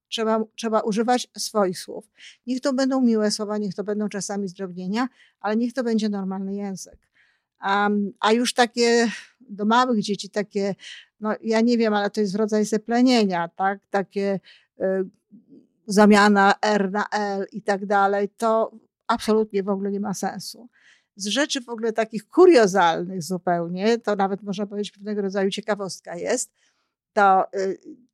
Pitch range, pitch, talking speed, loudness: 200-225 Hz, 210 Hz, 155 wpm, -22 LUFS